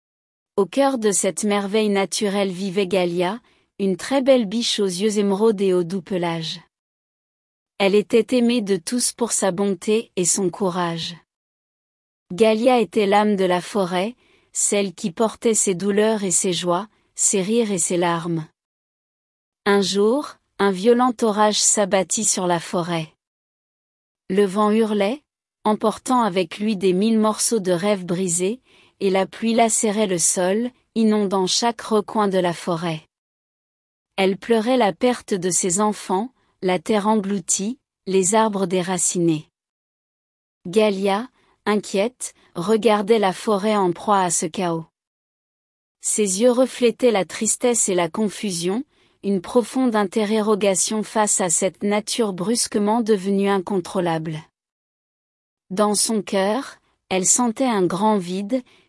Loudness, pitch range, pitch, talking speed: -20 LUFS, 185-220 Hz, 205 Hz, 135 wpm